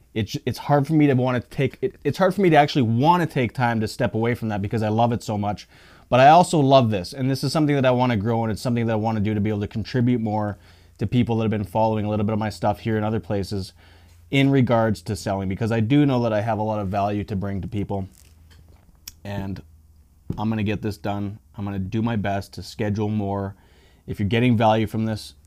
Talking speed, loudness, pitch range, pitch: 265 wpm, -22 LUFS, 100-120 Hz, 110 Hz